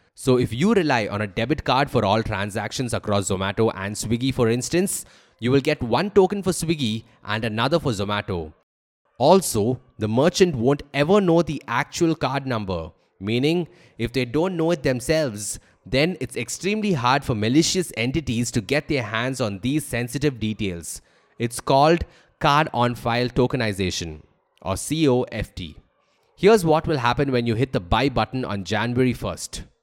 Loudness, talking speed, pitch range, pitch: -22 LUFS, 165 wpm, 110-150 Hz, 125 Hz